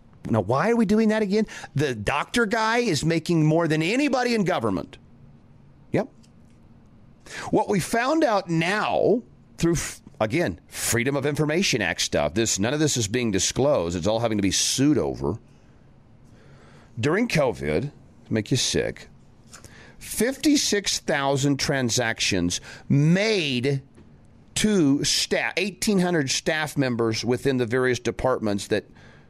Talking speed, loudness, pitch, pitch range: 125 wpm, -23 LUFS, 140 Hz, 115-190 Hz